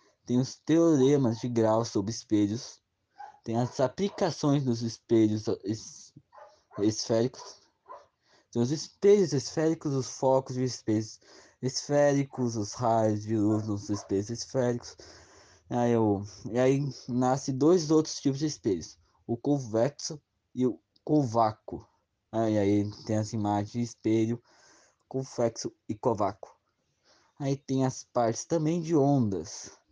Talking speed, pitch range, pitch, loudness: 125 wpm, 110-140 Hz, 125 Hz, -28 LUFS